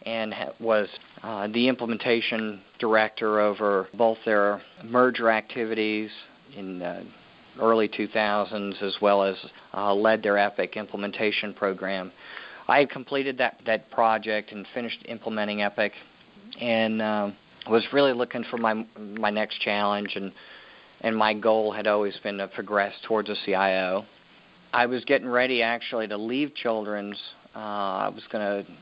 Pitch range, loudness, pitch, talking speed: 100-115 Hz, -26 LUFS, 110 Hz, 145 wpm